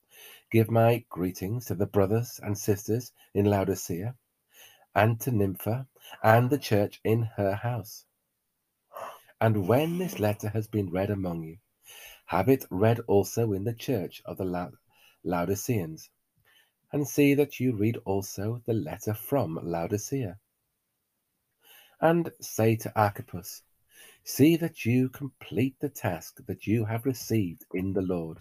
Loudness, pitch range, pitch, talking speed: -28 LUFS, 100-120 Hz, 110 Hz, 140 wpm